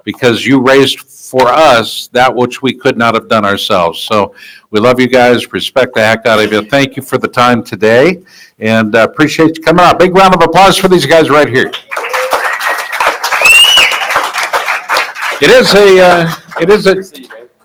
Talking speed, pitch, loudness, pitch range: 175 wpm, 135 Hz, -8 LUFS, 120-165 Hz